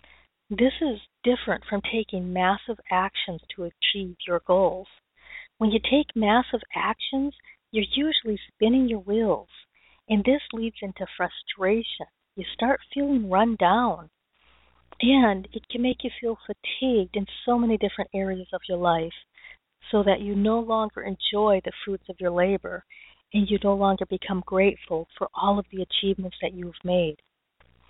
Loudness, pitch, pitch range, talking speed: -25 LUFS, 205 Hz, 185-230 Hz, 155 wpm